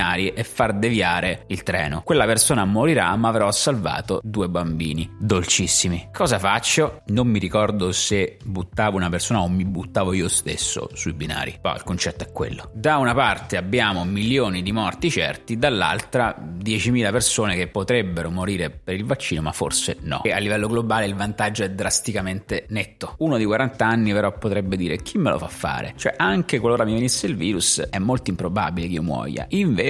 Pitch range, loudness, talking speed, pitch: 90-115 Hz, -21 LUFS, 180 wpm, 100 Hz